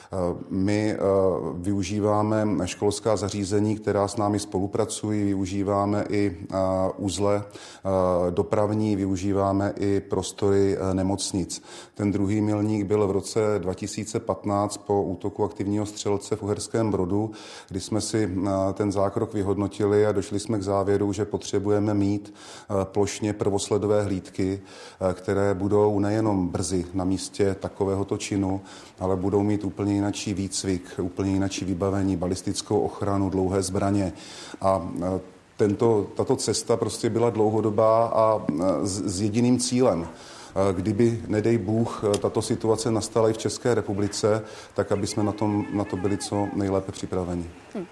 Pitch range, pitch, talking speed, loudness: 95-105 Hz, 100 Hz, 125 wpm, -25 LUFS